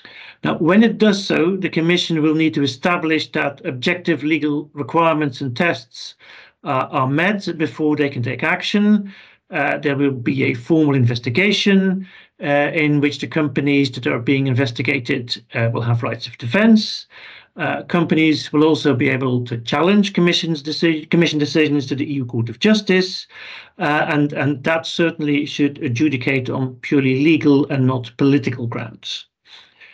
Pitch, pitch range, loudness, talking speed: 150 Hz, 135-170 Hz, -18 LUFS, 160 wpm